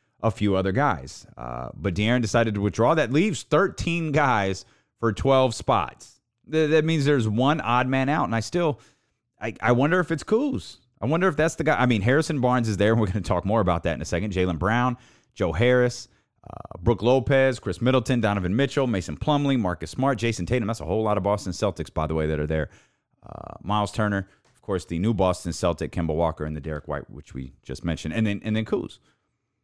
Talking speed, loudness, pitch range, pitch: 225 wpm, -24 LUFS, 90-130 Hz, 110 Hz